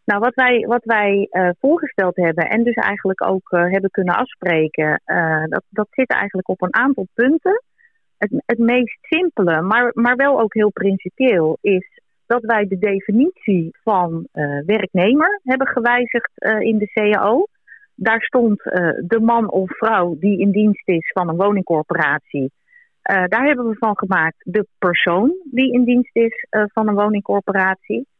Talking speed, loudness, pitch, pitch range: 170 wpm, -17 LUFS, 210 Hz, 185-245 Hz